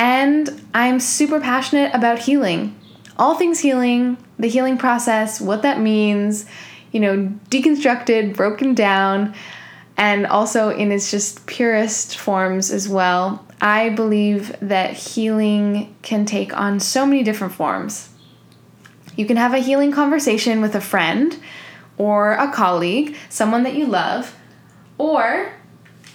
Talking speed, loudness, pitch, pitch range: 130 wpm, -18 LUFS, 215 Hz, 200-255 Hz